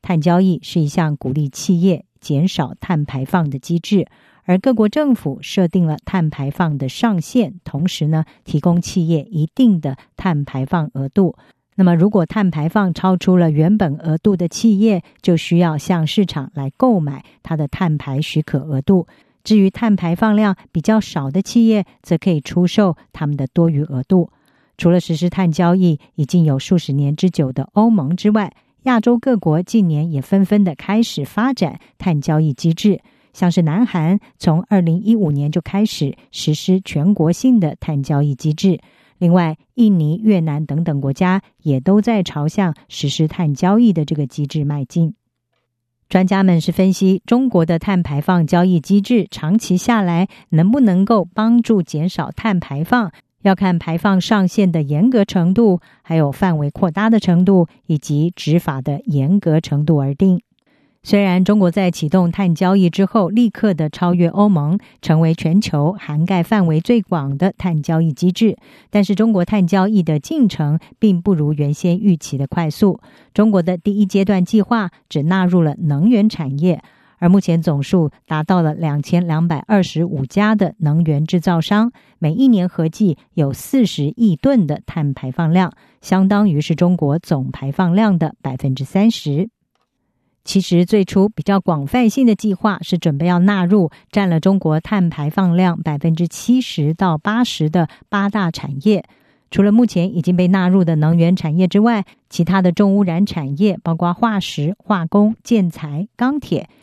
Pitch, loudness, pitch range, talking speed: 180 Hz, -16 LUFS, 155-200 Hz, 255 characters per minute